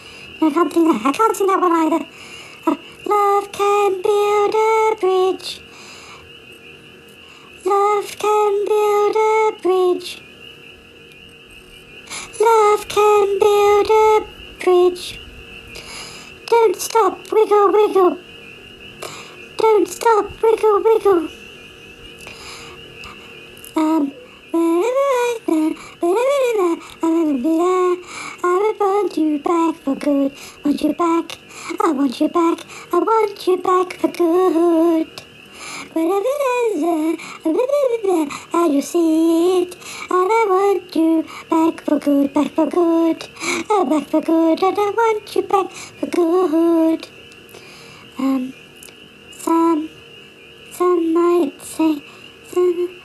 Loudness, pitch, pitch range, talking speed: -17 LUFS, 360 Hz, 330-415 Hz, 105 wpm